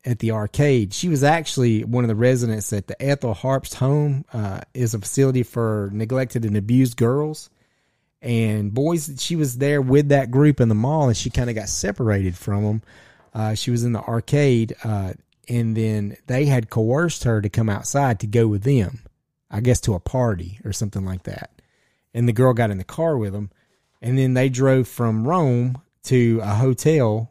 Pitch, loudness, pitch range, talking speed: 120 Hz, -21 LUFS, 110-135 Hz, 200 wpm